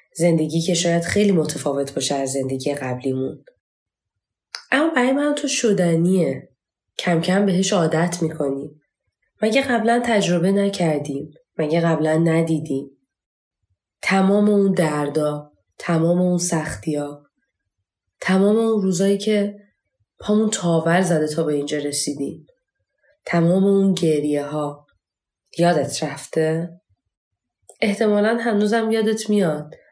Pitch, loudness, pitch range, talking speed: 165 Hz, -20 LUFS, 145-200 Hz, 105 wpm